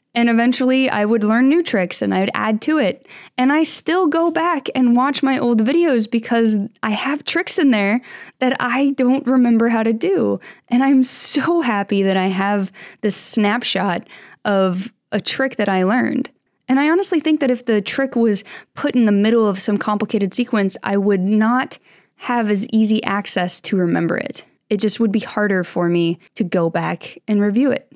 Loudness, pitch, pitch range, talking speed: -17 LUFS, 230 Hz, 205-265 Hz, 195 wpm